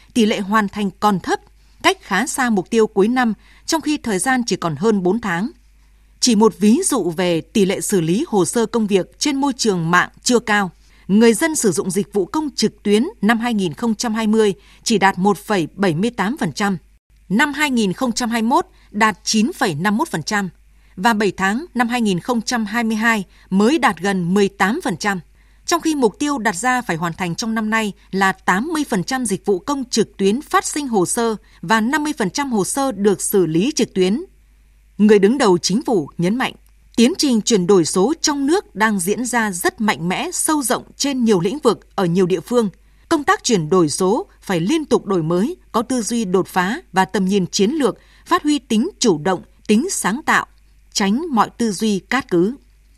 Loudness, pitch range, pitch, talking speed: -18 LUFS, 195-250 Hz, 220 Hz, 185 wpm